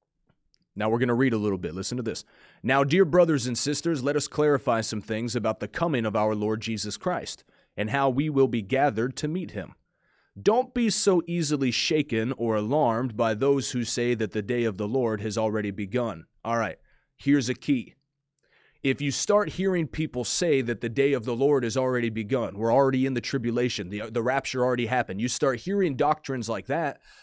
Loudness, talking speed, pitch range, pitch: -26 LUFS, 205 wpm, 115-145 Hz, 125 Hz